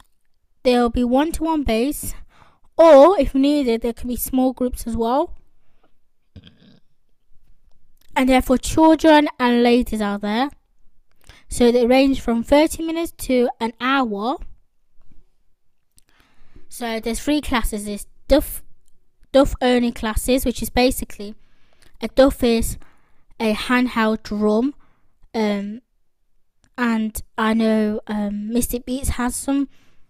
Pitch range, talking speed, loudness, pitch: 225-270 Hz, 115 wpm, -19 LUFS, 245 Hz